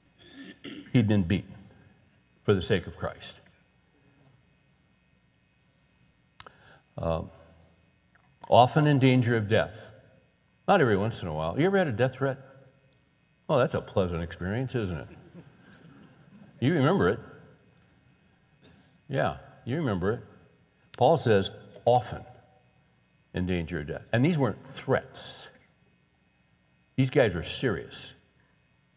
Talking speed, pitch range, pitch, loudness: 115 wpm, 90-130 Hz, 110 Hz, -27 LUFS